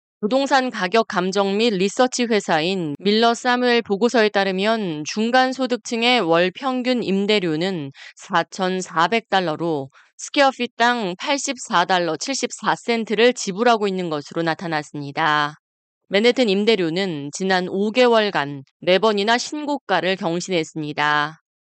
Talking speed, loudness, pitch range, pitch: 255 characters per minute, -20 LUFS, 170-240 Hz, 200 Hz